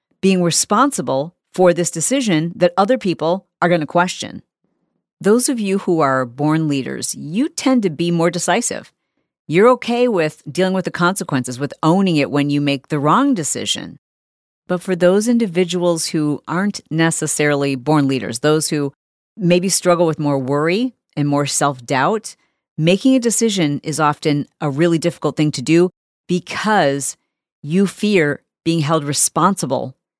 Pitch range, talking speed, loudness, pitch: 150-190 Hz, 155 wpm, -17 LUFS, 170 Hz